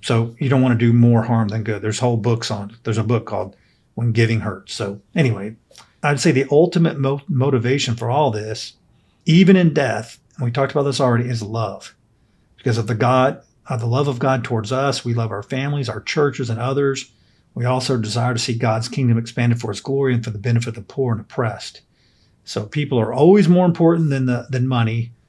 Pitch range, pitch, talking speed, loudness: 115-135 Hz, 120 Hz, 220 wpm, -19 LUFS